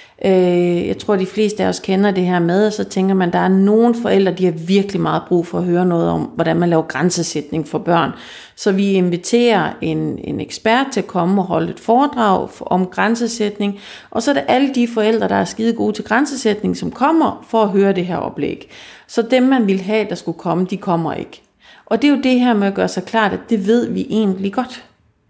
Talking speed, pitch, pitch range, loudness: 235 wpm, 195 Hz, 175-225 Hz, -16 LUFS